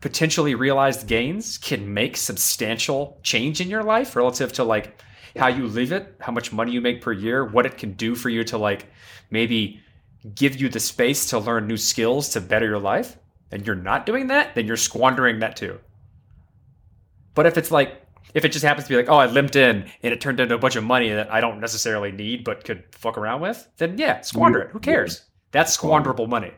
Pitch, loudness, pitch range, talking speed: 115 Hz, -21 LUFS, 110-135 Hz, 220 wpm